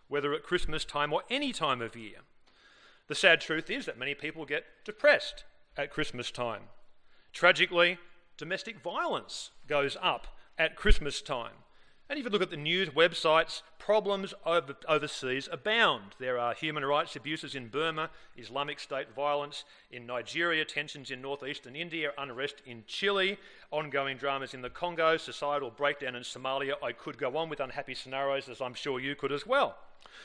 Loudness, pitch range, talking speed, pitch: -31 LUFS, 135-170 Hz, 165 wpm, 145 Hz